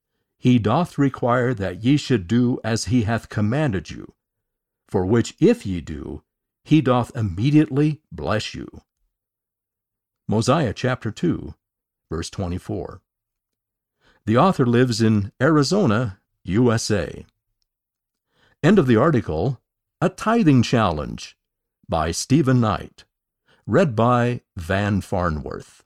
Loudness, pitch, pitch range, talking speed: -21 LUFS, 115 Hz, 105-125 Hz, 110 wpm